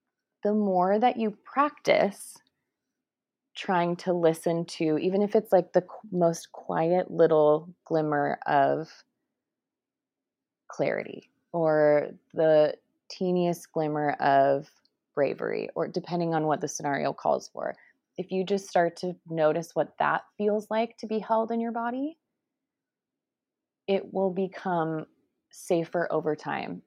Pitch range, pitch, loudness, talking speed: 160-210 Hz, 180 Hz, -27 LUFS, 125 wpm